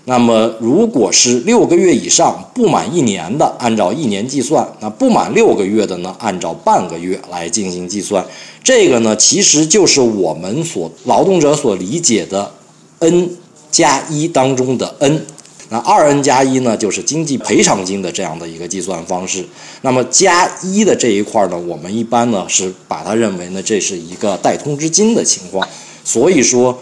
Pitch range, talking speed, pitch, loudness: 100-155 Hz, 270 characters per minute, 125 Hz, -13 LUFS